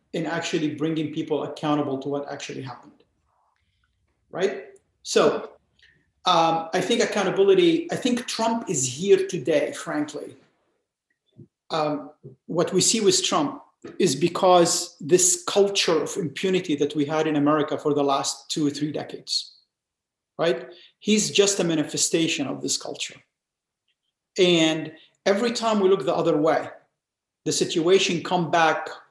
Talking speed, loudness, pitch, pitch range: 135 wpm, -23 LUFS, 170 Hz, 150-195 Hz